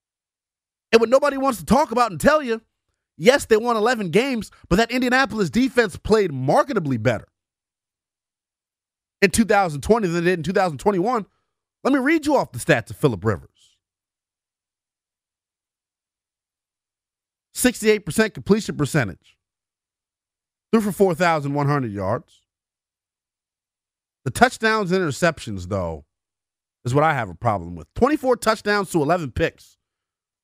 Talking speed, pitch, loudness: 125 wpm, 125 Hz, -20 LUFS